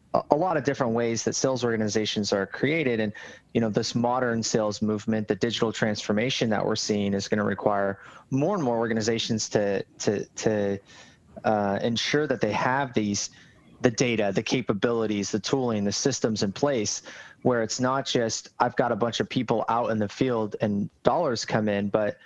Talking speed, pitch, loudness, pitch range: 185 wpm, 110 Hz, -26 LUFS, 105-120 Hz